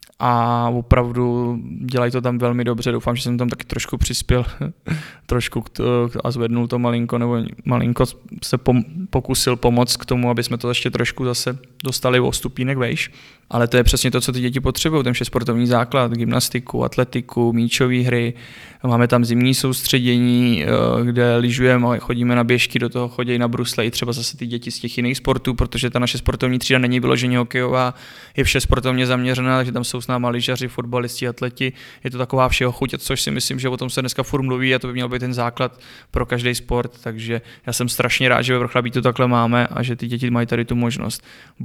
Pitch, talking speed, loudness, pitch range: 125 Hz, 205 wpm, -19 LUFS, 120-125 Hz